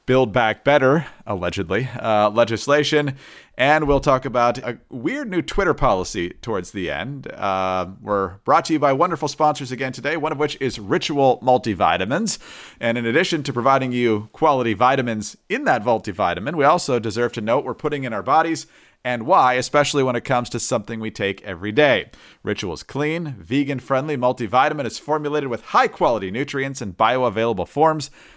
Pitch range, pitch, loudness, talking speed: 115-145 Hz, 130 Hz, -20 LUFS, 165 wpm